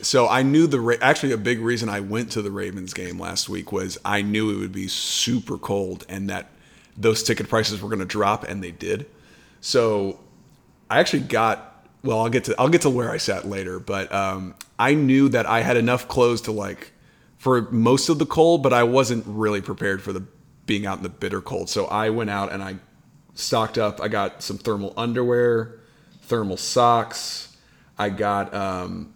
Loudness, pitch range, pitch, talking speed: -22 LUFS, 100-120 Hz, 110 Hz, 205 wpm